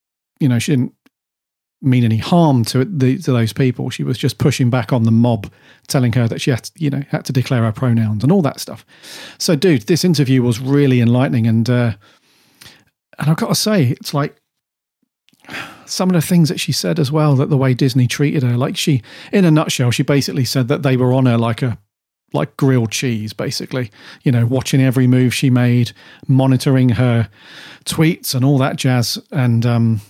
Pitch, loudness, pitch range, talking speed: 130 Hz, -16 LUFS, 120-145 Hz, 205 wpm